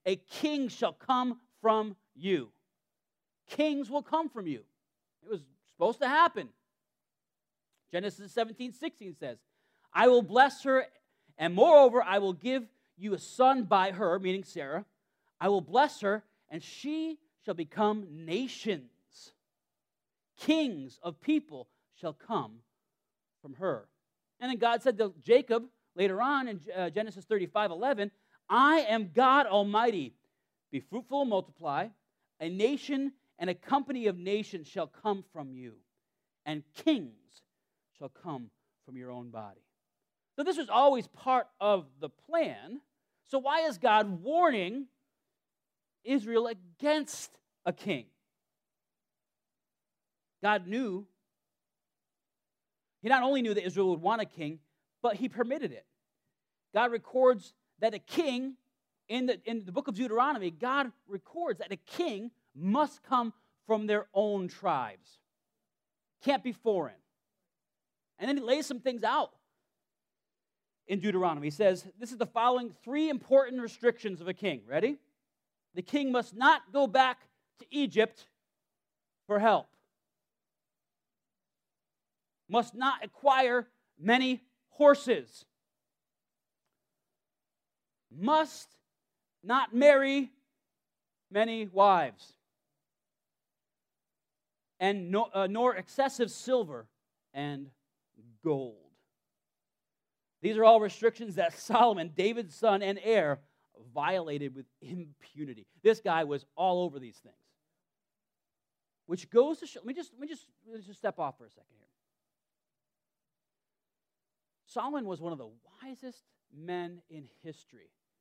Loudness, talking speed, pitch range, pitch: -30 LUFS, 125 wpm, 185-260 Hz, 220 Hz